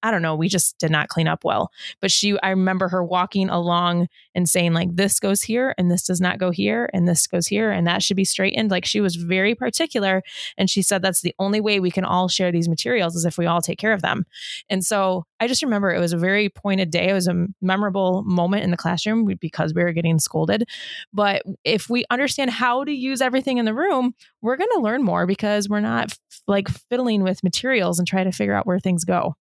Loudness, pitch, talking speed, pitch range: -20 LUFS, 190 Hz, 245 wpm, 175-210 Hz